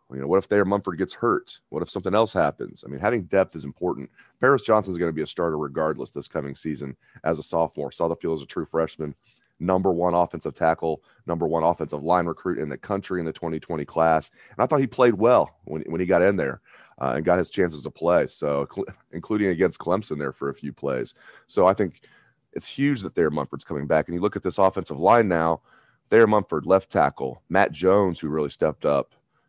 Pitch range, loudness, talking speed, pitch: 80-100 Hz, -24 LUFS, 225 wpm, 90 Hz